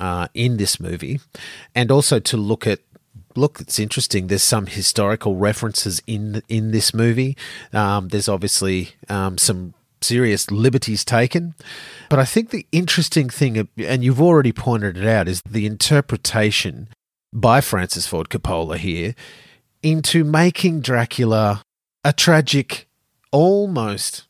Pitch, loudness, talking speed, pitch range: 115 Hz, -18 LUFS, 135 wpm, 100-140 Hz